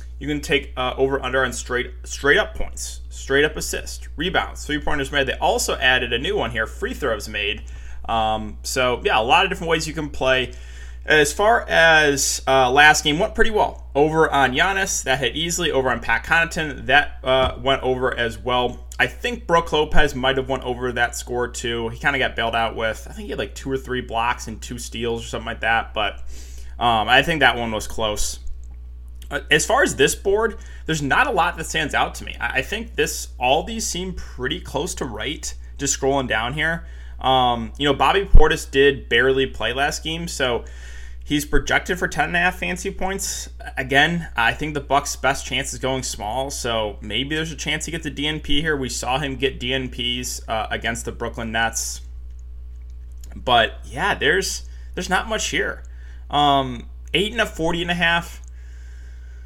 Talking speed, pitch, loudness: 200 wpm, 125 Hz, -20 LUFS